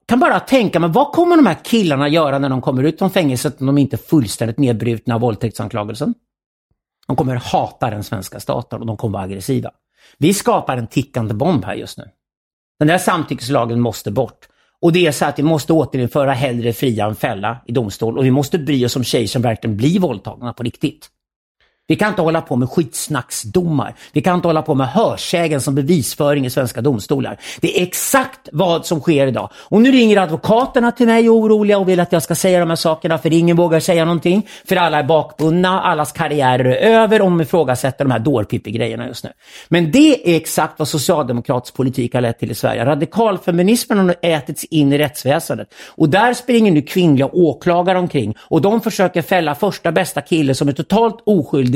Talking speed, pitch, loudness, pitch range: 205 wpm, 150 Hz, -16 LUFS, 130-180 Hz